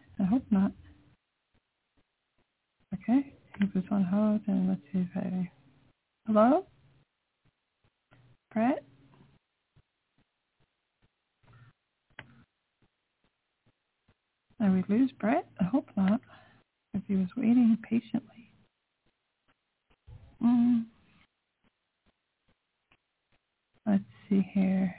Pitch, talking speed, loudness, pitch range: 210 Hz, 70 wpm, -29 LUFS, 190-235 Hz